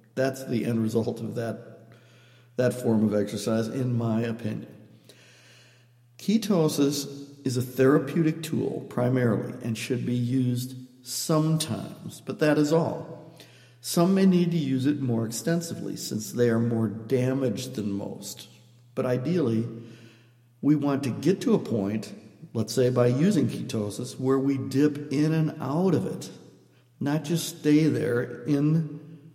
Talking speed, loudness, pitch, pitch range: 145 wpm, -26 LUFS, 130 Hz, 115-150 Hz